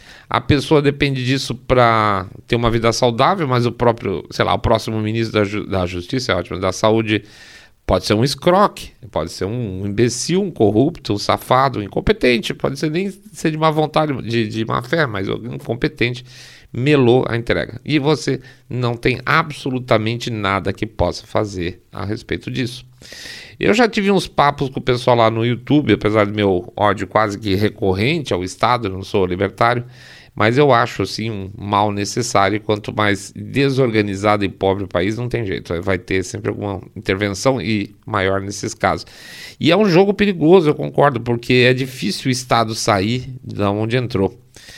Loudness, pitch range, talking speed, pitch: -18 LUFS, 105-130 Hz, 180 wpm, 115 Hz